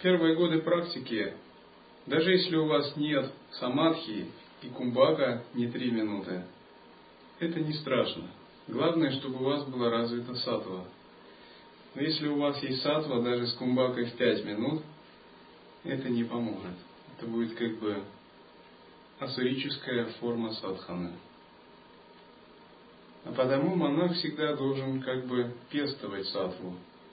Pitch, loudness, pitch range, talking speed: 125 Hz, -31 LUFS, 110-145 Hz, 120 wpm